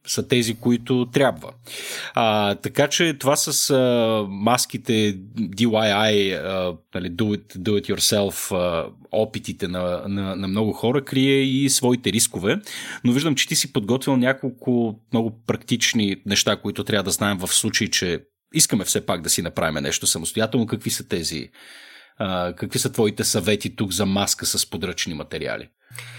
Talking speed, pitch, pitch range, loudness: 160 wpm, 110 Hz, 100-125 Hz, -21 LUFS